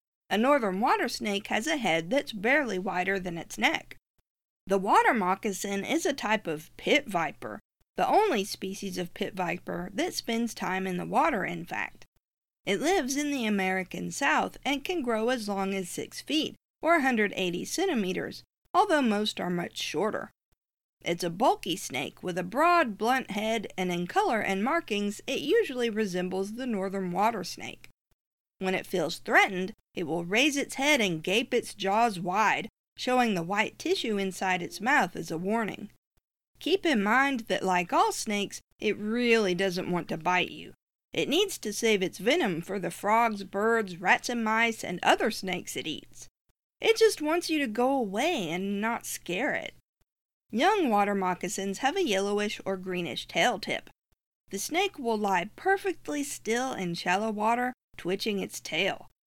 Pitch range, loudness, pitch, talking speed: 185-250 Hz, -28 LUFS, 210 Hz, 170 wpm